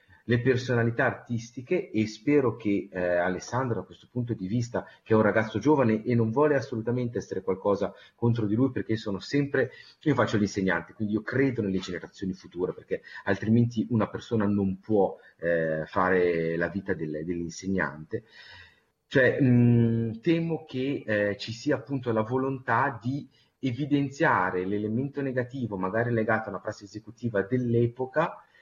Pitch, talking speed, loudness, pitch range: 115 Hz, 145 wpm, -27 LUFS, 100-130 Hz